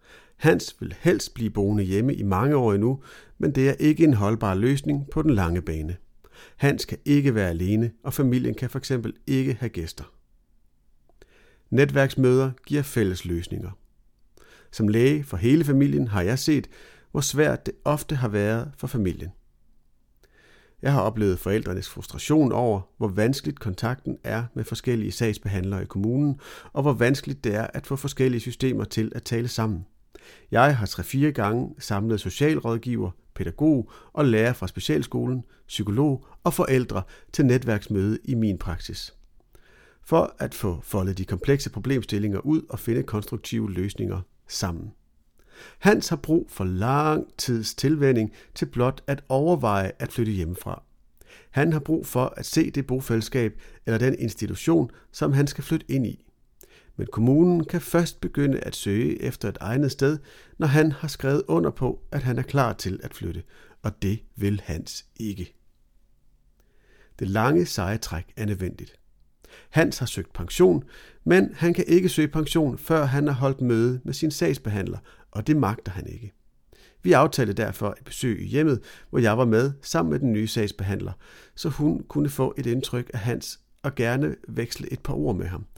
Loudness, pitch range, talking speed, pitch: -25 LUFS, 105-140 Hz, 165 wpm, 120 Hz